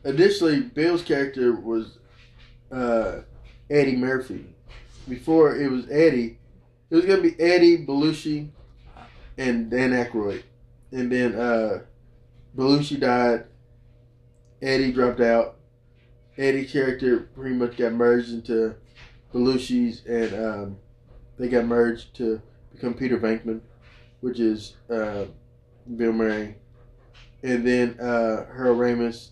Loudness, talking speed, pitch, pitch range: -23 LUFS, 115 wpm, 120 Hz, 120-130 Hz